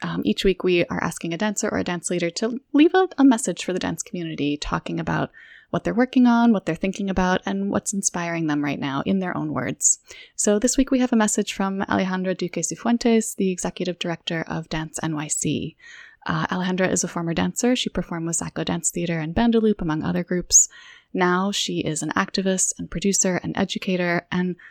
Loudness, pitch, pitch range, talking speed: -22 LUFS, 185 Hz, 170-220 Hz, 205 wpm